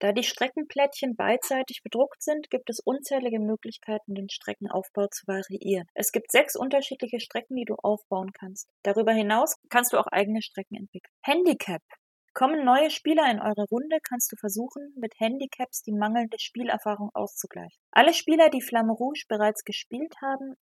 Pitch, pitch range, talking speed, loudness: 235 Hz, 210-270 Hz, 160 wpm, -26 LUFS